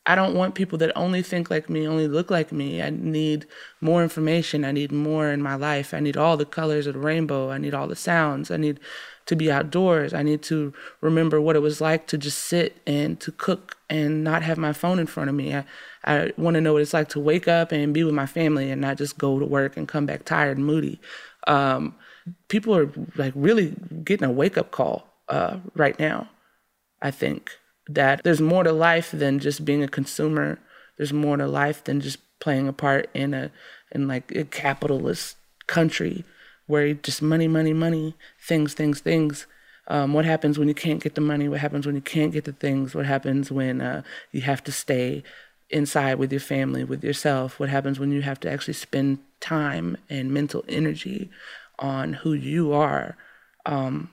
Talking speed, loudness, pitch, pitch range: 210 wpm, -24 LUFS, 150 Hz, 140-160 Hz